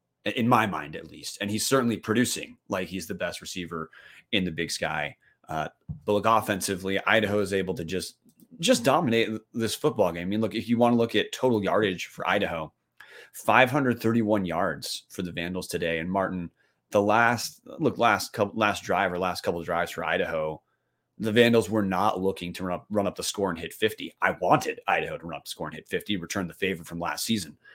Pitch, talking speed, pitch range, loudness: 100 Hz, 215 wpm, 90-110 Hz, -26 LUFS